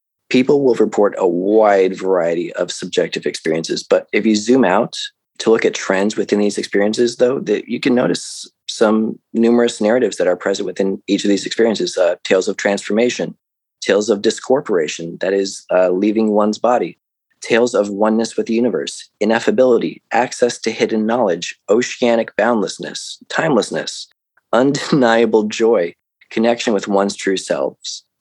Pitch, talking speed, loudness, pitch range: 110 Hz, 150 wpm, -16 LUFS, 100-115 Hz